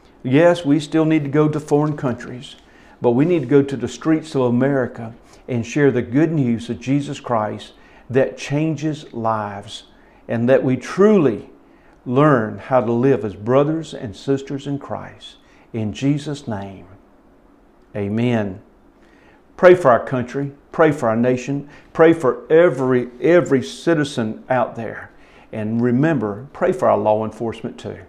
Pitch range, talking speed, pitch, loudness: 115-145 Hz, 150 wpm, 130 Hz, -18 LUFS